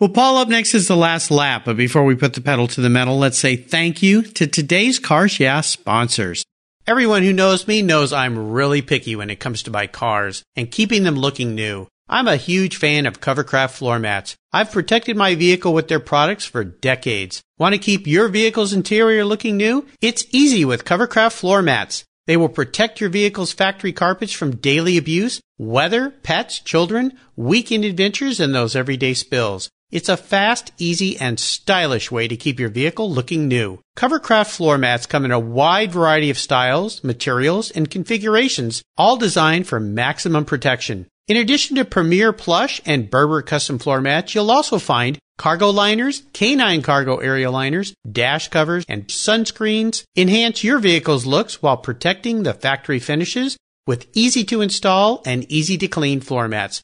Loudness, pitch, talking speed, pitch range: -17 LUFS, 160 Hz, 175 wpm, 130-210 Hz